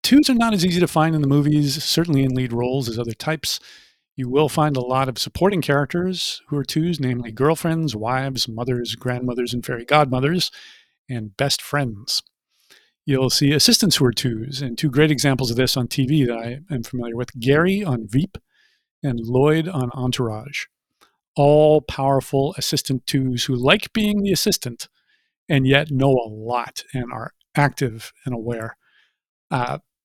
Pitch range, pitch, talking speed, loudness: 125-155 Hz, 140 Hz, 170 wpm, -20 LUFS